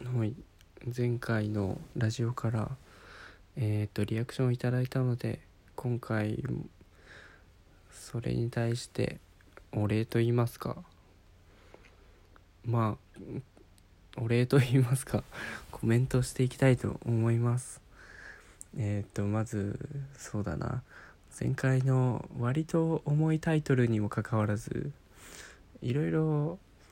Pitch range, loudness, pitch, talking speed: 105-130 Hz, -31 LUFS, 115 Hz, 220 characters per minute